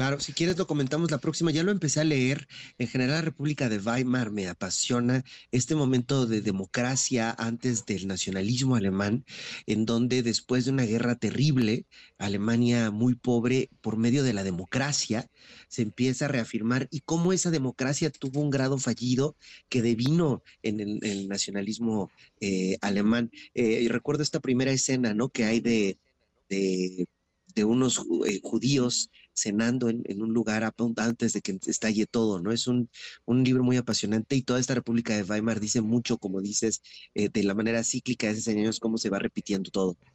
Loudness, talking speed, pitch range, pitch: -27 LUFS, 180 wpm, 110-130 Hz, 120 Hz